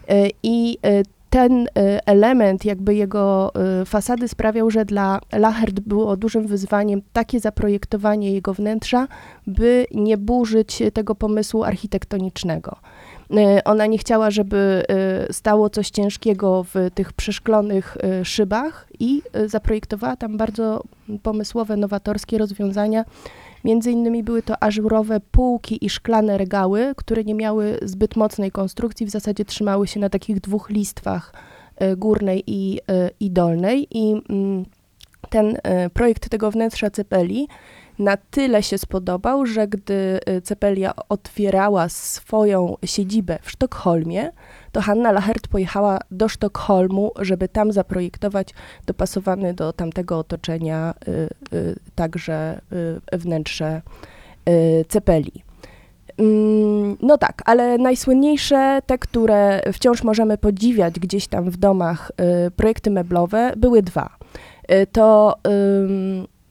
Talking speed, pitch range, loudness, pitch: 120 wpm, 195-220 Hz, -19 LUFS, 210 Hz